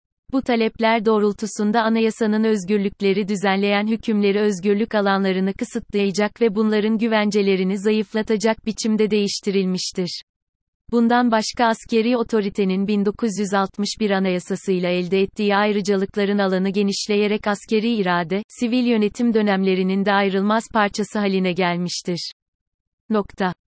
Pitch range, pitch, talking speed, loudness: 195-220 Hz, 205 Hz, 95 wpm, -20 LUFS